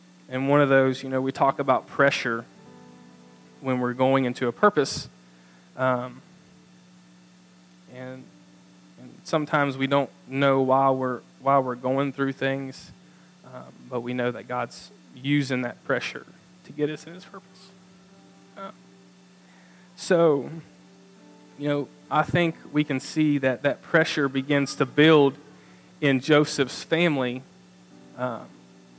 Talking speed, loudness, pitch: 135 wpm, -24 LUFS, 135 Hz